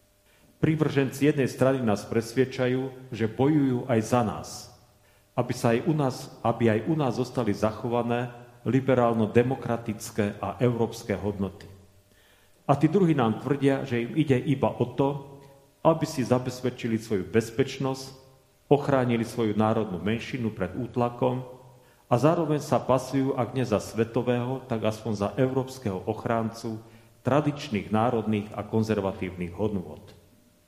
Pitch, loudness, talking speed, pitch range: 120 Hz, -27 LUFS, 125 wpm, 110-130 Hz